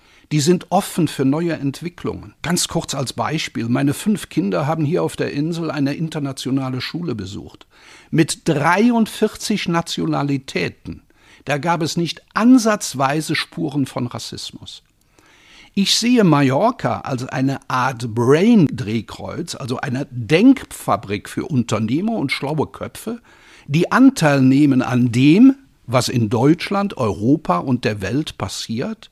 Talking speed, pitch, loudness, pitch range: 125 wpm, 145 Hz, -18 LUFS, 130-170 Hz